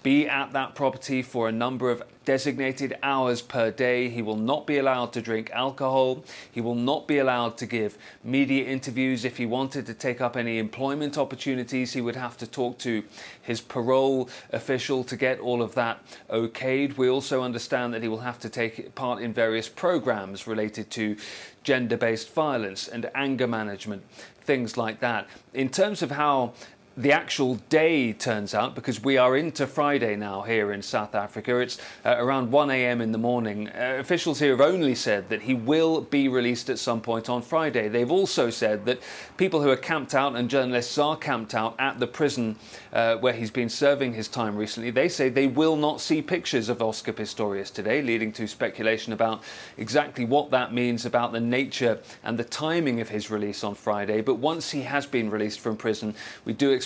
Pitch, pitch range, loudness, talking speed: 125 Hz, 115-135 Hz, -26 LUFS, 195 wpm